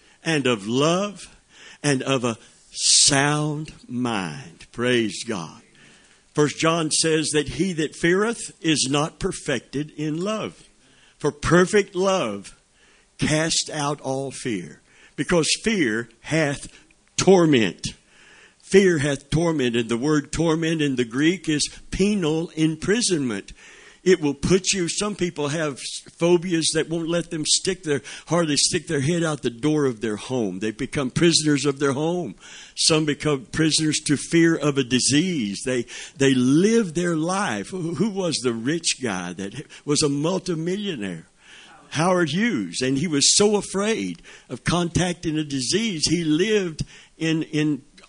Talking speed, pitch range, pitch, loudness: 140 wpm, 140-175 Hz, 155 Hz, -22 LUFS